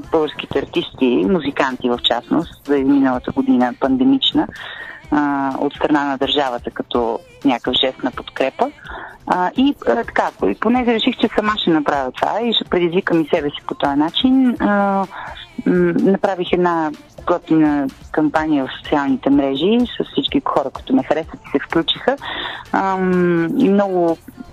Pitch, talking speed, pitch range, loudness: 160 Hz, 130 wpm, 140-195 Hz, -18 LUFS